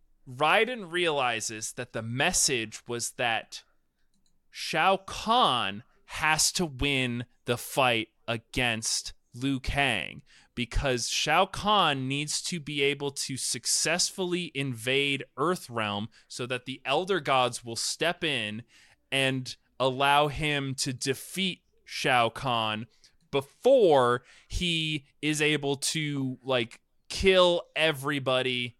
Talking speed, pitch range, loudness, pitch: 105 wpm, 120-155 Hz, -27 LUFS, 135 Hz